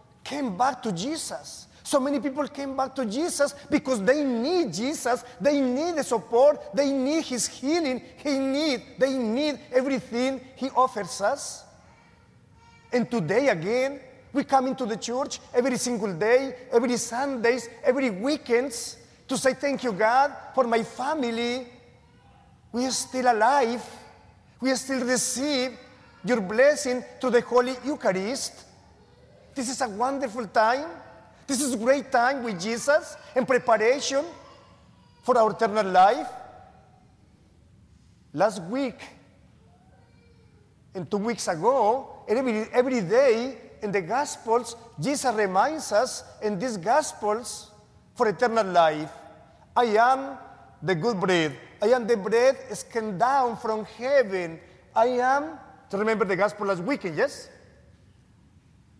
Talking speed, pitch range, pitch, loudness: 130 wpm, 225-270 Hz, 250 Hz, -25 LUFS